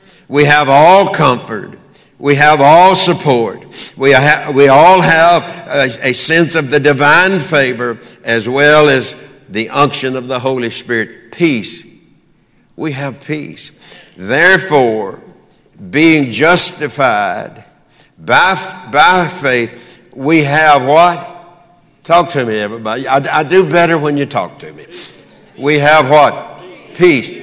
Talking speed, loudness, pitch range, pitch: 130 wpm, -9 LUFS, 130-170 Hz, 145 Hz